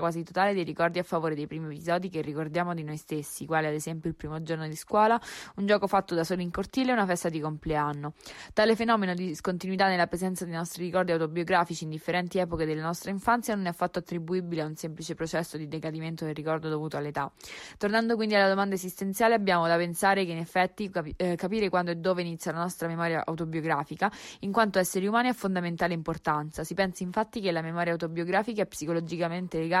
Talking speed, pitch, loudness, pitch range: 205 wpm, 175 Hz, -29 LUFS, 160-190 Hz